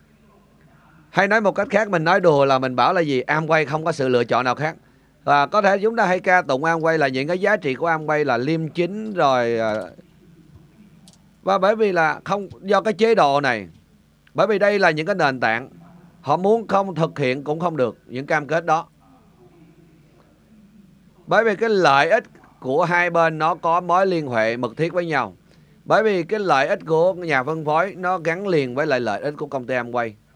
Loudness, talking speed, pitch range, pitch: -20 LUFS, 215 wpm, 150-190 Hz, 170 Hz